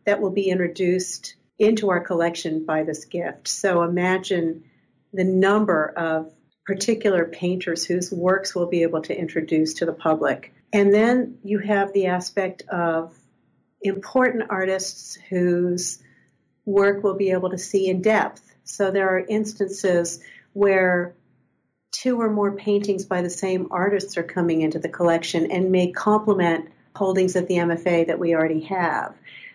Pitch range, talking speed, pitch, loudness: 170-200 Hz, 150 wpm, 185 Hz, -22 LUFS